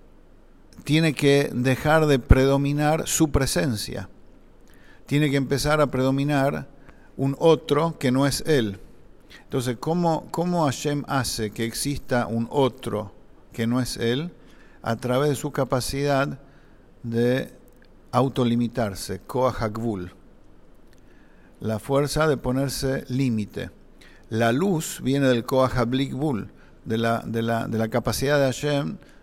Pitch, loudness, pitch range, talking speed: 130 Hz, -24 LUFS, 115-145 Hz, 120 wpm